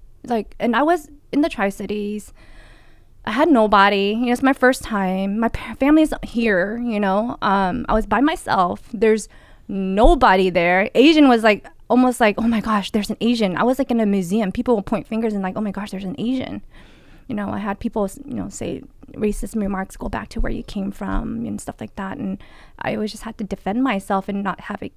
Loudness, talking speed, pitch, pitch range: -20 LUFS, 220 wpm, 220 Hz, 200-240 Hz